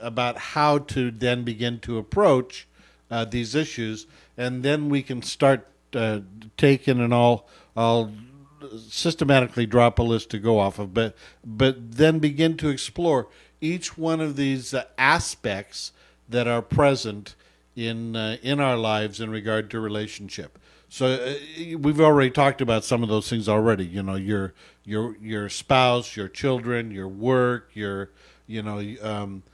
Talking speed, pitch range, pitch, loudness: 155 wpm, 110-135 Hz, 120 Hz, -23 LUFS